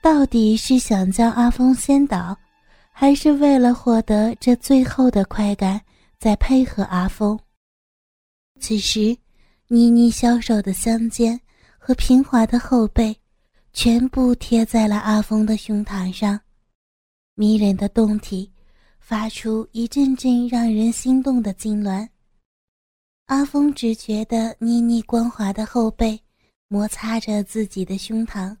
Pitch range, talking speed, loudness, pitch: 210-245 Hz, 185 characters per minute, -19 LUFS, 225 Hz